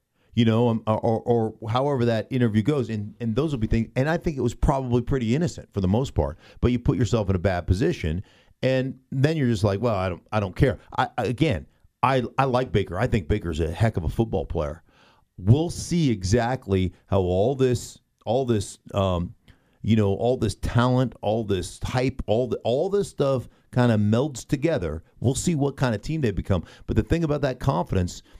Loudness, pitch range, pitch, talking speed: -24 LUFS, 100-130 Hz, 115 Hz, 215 wpm